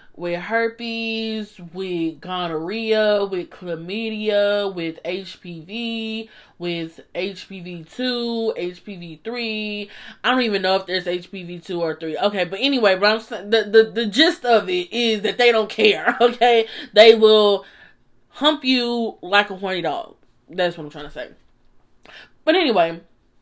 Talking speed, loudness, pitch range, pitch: 135 wpm, -20 LUFS, 175-225 Hz, 205 Hz